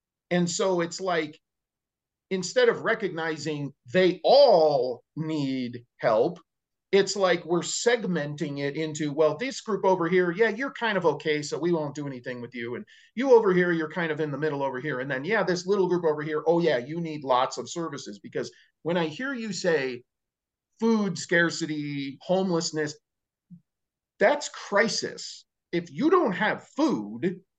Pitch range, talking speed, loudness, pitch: 150-190 Hz, 170 wpm, -26 LUFS, 165 Hz